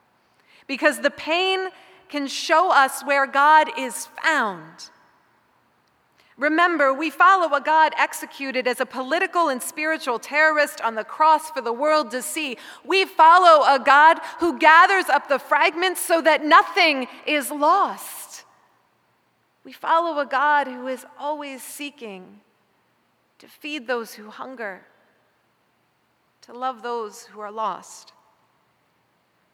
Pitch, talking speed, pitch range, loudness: 295 Hz, 130 wpm, 265-320 Hz, -19 LUFS